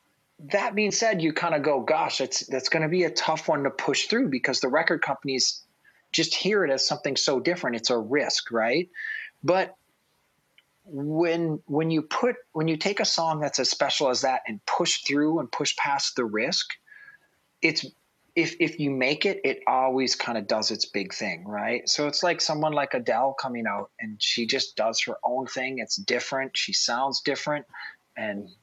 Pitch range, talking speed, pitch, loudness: 140-195 Hz, 195 wpm, 160 Hz, -25 LUFS